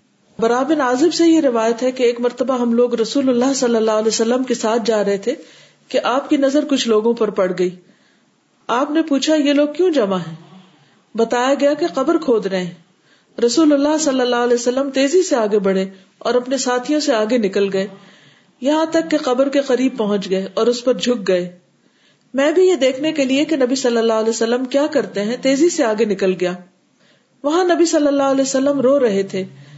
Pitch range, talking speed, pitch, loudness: 215-280 Hz, 210 wpm, 245 Hz, -17 LUFS